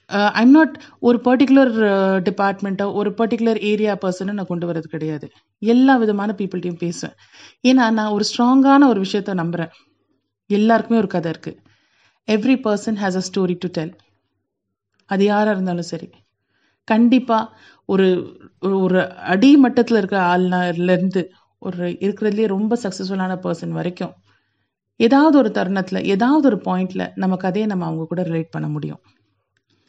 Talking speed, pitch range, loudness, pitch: 130 wpm, 175-220 Hz, -18 LUFS, 195 Hz